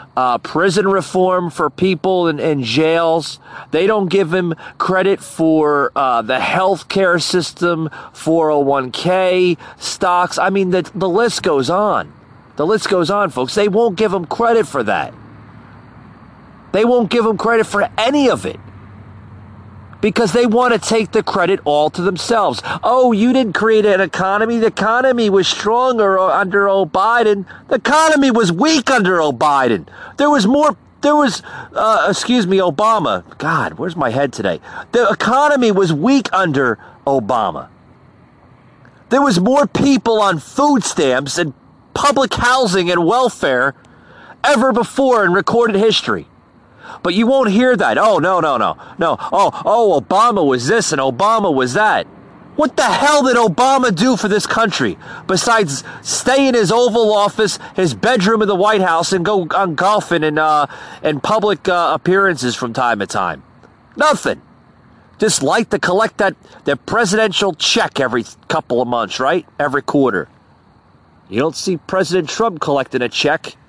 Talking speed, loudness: 155 wpm, -15 LUFS